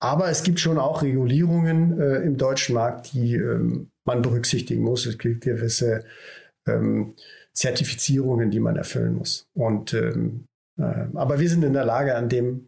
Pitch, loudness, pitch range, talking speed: 130 Hz, -23 LUFS, 120-155 Hz, 165 wpm